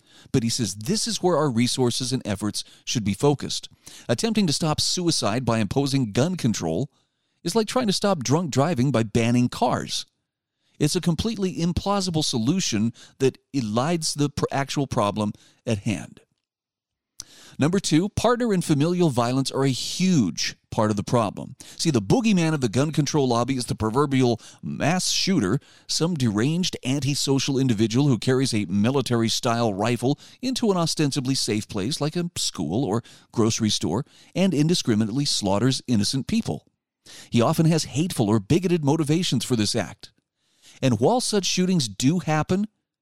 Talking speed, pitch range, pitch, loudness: 155 wpm, 120-165 Hz, 135 Hz, -23 LUFS